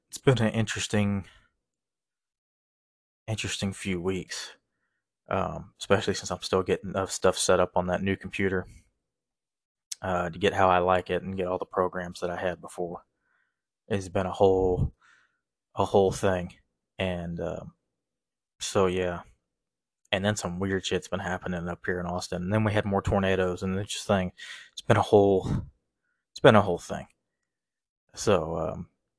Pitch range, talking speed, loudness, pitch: 90-100 Hz, 160 wpm, -27 LUFS, 95 Hz